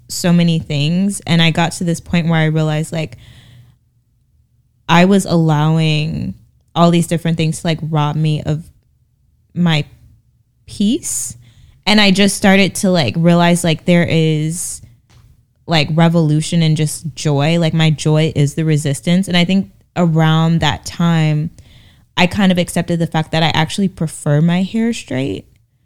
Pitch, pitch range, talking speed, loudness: 160 Hz, 140-170 Hz, 155 wpm, -15 LUFS